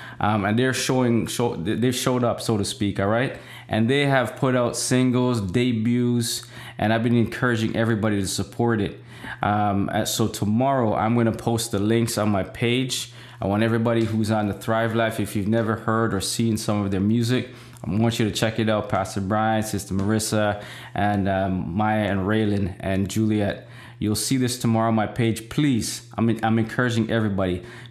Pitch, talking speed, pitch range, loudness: 115 Hz, 190 wpm, 105-120 Hz, -23 LUFS